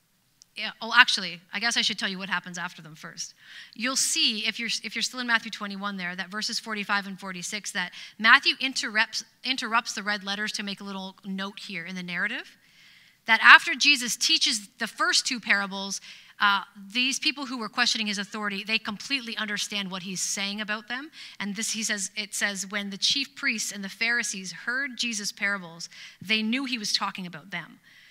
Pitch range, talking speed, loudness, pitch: 195-235 Hz, 200 wpm, -25 LUFS, 210 Hz